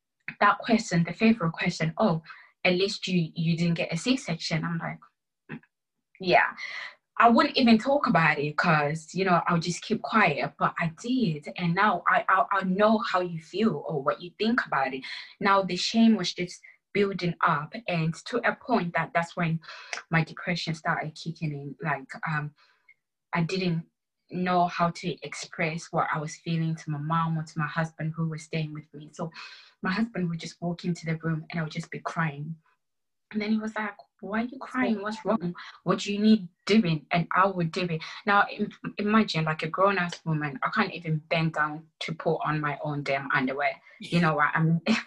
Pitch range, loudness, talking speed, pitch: 160-200 Hz, -27 LUFS, 200 wpm, 170 Hz